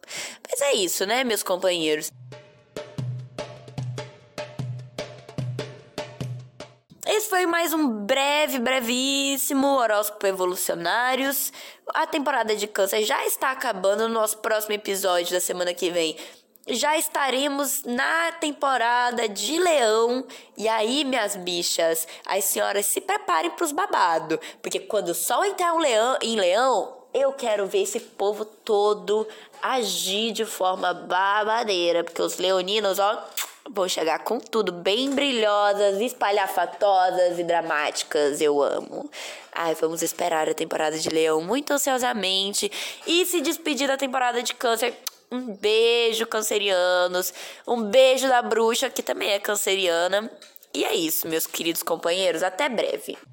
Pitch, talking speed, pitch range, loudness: 215 Hz, 130 wpm, 180-270 Hz, -23 LUFS